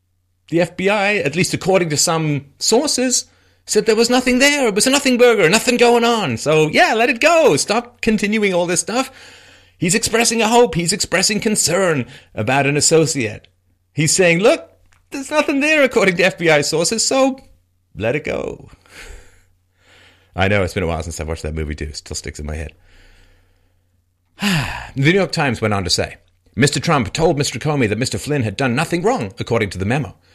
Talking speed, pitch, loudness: 190 wpm, 150 Hz, -16 LUFS